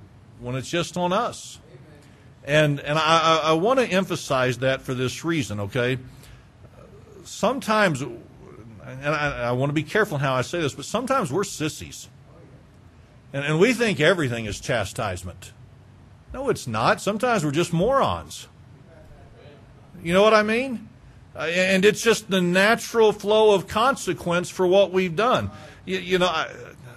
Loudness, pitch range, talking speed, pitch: -22 LUFS, 125-190 Hz, 155 wpm, 155 Hz